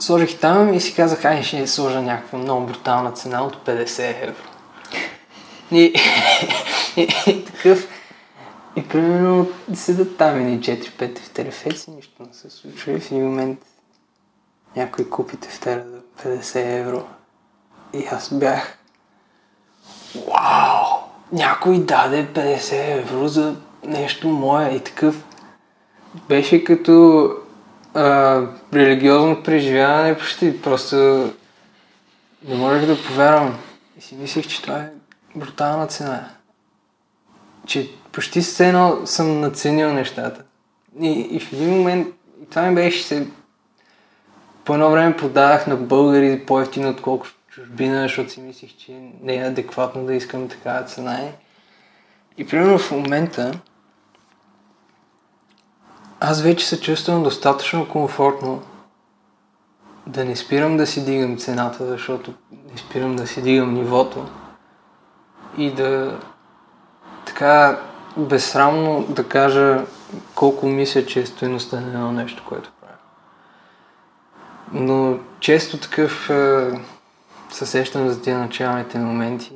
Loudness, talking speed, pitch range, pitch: -18 LUFS, 120 wpm, 130-155 Hz, 140 Hz